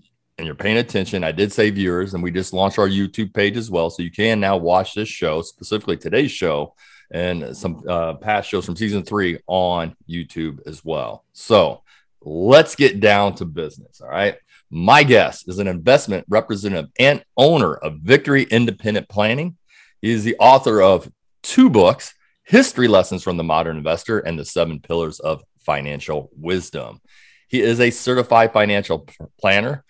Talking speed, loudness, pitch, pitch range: 170 wpm, -18 LUFS, 95 Hz, 85-110 Hz